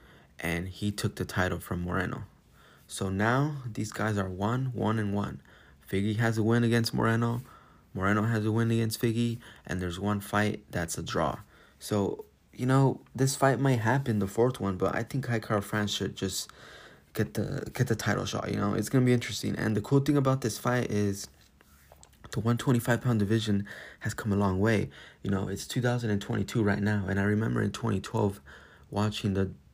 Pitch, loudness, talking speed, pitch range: 105 Hz, -29 LUFS, 205 wpm, 100-120 Hz